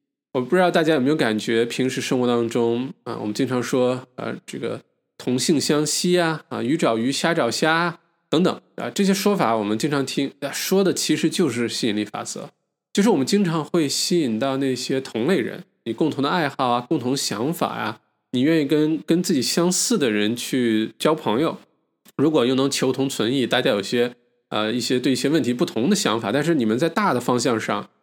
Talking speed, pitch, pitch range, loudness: 300 characters per minute, 135 Hz, 120-165 Hz, -21 LUFS